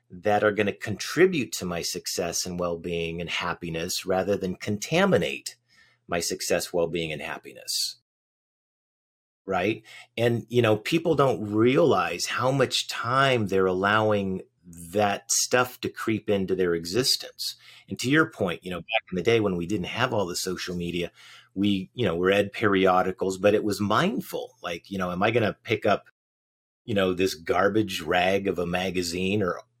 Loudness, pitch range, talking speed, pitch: -25 LUFS, 90-105 Hz, 175 wpm, 95 Hz